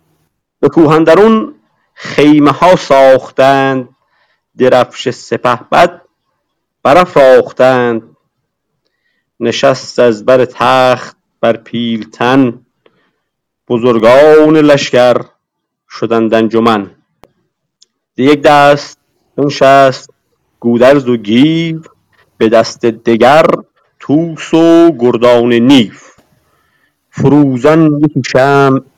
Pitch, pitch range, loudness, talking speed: 135 Hz, 120-150 Hz, -8 LUFS, 70 wpm